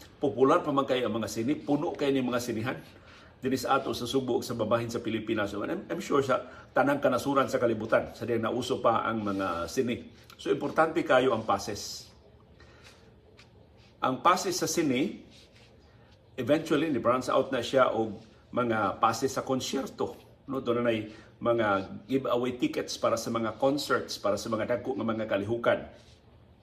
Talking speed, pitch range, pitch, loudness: 165 wpm, 110-130 Hz, 115 Hz, -29 LUFS